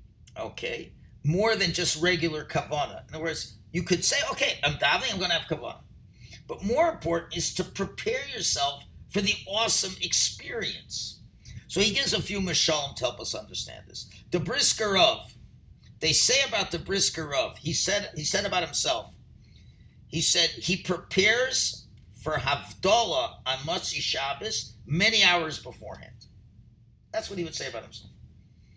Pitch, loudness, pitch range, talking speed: 165 Hz, -25 LUFS, 120-190 Hz, 160 wpm